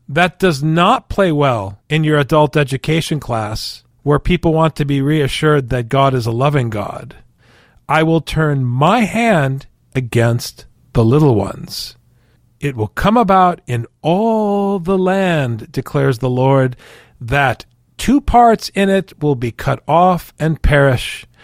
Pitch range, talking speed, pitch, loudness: 125-170 Hz, 150 wpm, 145 Hz, -15 LUFS